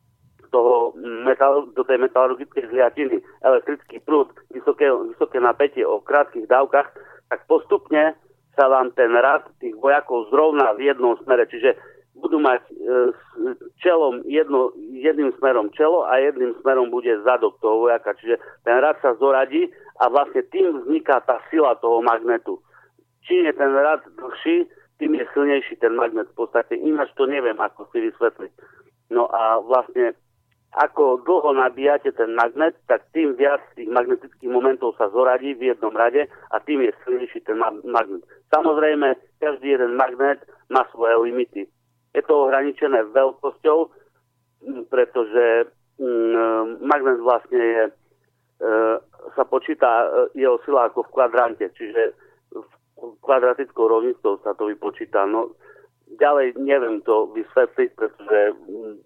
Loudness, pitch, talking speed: -20 LUFS, 280 Hz, 140 wpm